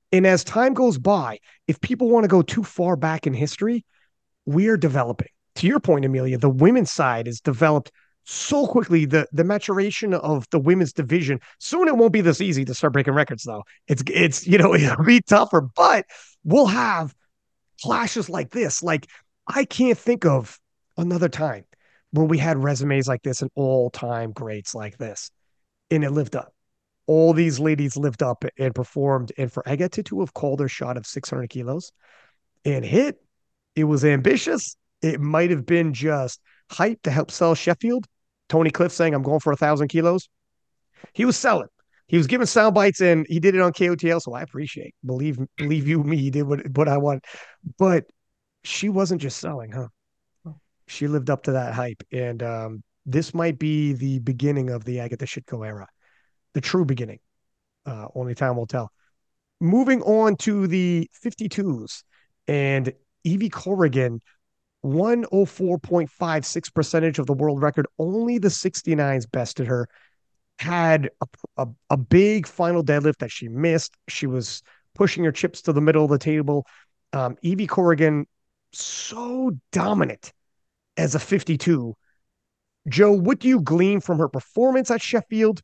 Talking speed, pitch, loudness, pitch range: 170 wpm, 155 Hz, -21 LUFS, 135-180 Hz